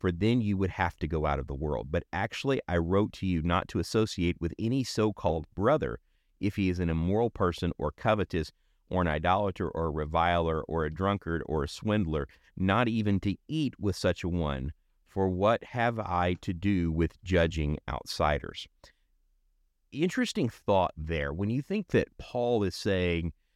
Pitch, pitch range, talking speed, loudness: 90 Hz, 80-100 Hz, 185 wpm, -30 LUFS